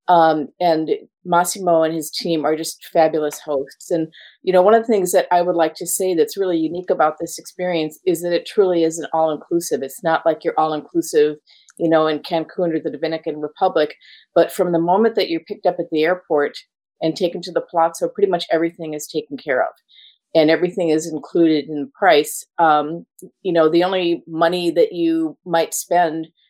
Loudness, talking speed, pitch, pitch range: -19 LUFS, 205 wpm, 165 Hz, 160-180 Hz